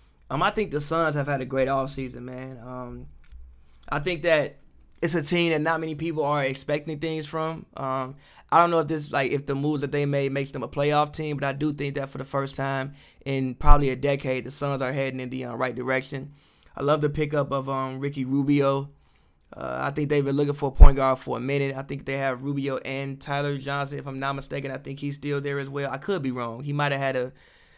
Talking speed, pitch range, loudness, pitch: 250 wpm, 135-145 Hz, -26 LUFS, 140 Hz